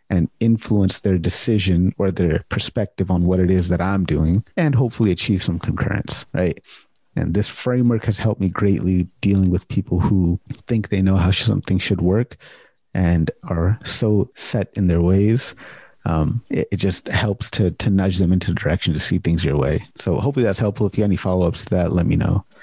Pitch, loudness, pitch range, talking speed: 95 Hz, -20 LUFS, 90-105 Hz, 200 wpm